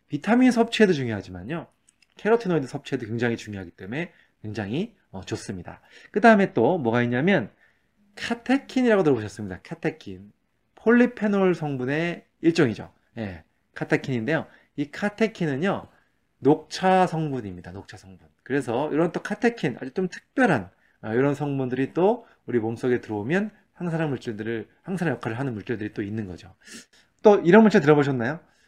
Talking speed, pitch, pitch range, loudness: 350 characters per minute, 145 Hz, 110-190 Hz, -24 LUFS